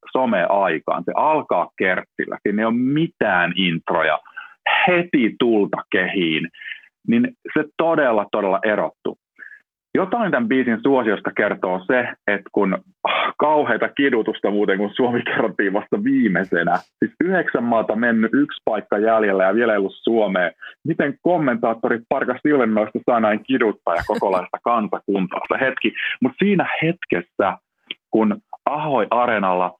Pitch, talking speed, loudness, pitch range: 120 Hz, 125 wpm, -20 LUFS, 105-170 Hz